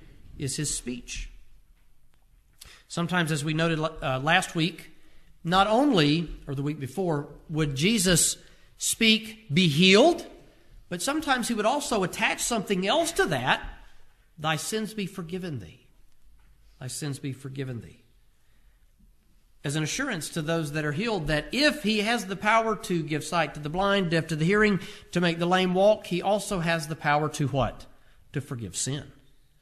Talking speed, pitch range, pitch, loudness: 160 wpm, 145-200 Hz, 165 Hz, -26 LUFS